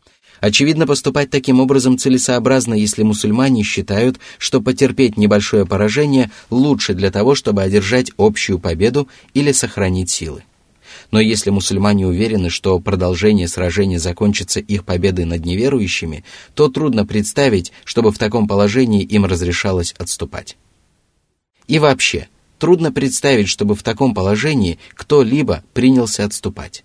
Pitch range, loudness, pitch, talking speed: 95-130 Hz, -15 LUFS, 105 Hz, 125 wpm